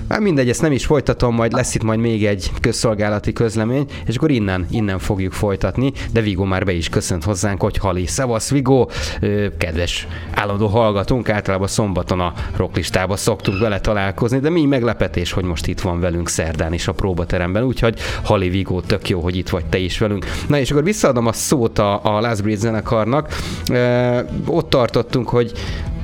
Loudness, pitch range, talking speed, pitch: -18 LUFS, 95-120 Hz, 180 wpm, 105 Hz